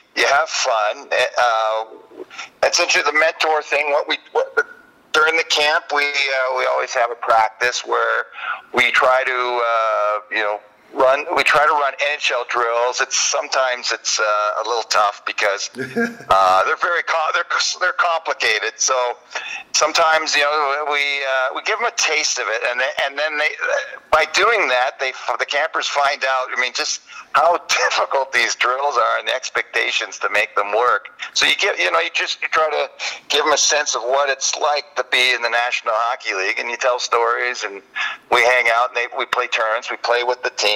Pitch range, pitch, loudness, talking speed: 120-155 Hz, 130 Hz, -18 LUFS, 200 wpm